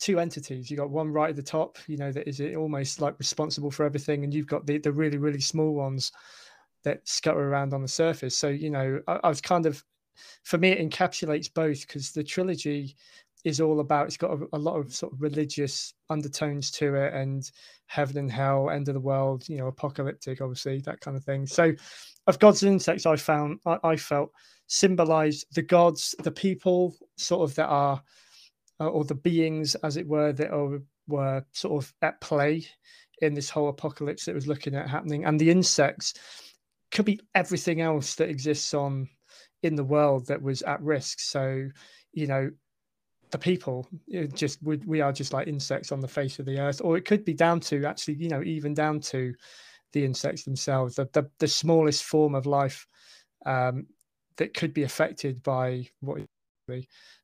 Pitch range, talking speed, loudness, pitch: 140-160 Hz, 200 wpm, -27 LUFS, 150 Hz